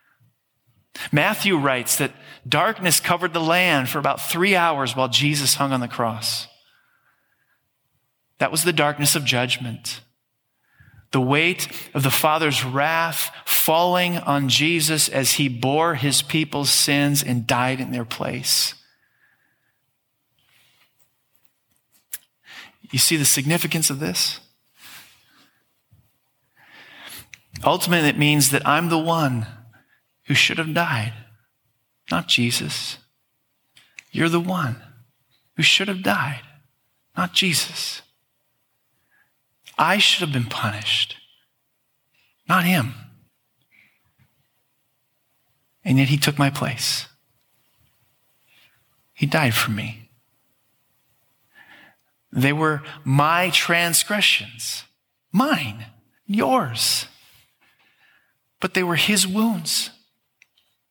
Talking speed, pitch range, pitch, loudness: 100 wpm, 125-165 Hz, 140 Hz, -20 LUFS